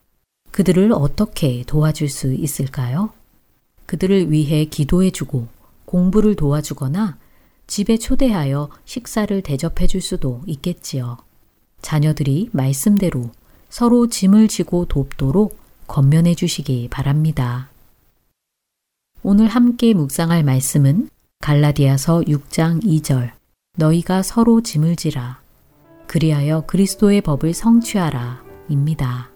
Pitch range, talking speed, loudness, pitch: 135-190 Hz, 250 characters per minute, -17 LUFS, 155 Hz